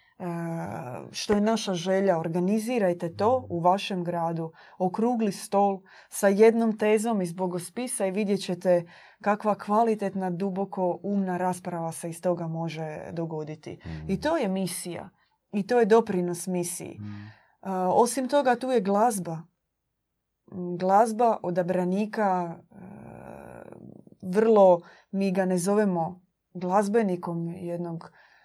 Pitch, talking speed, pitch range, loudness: 185 Hz, 110 wpm, 175-210 Hz, -26 LUFS